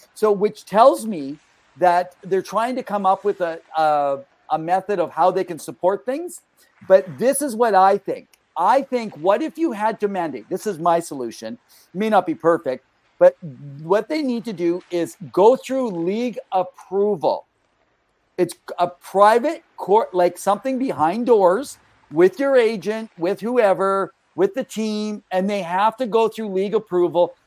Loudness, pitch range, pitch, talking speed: -20 LUFS, 175-225 Hz, 195 Hz, 170 wpm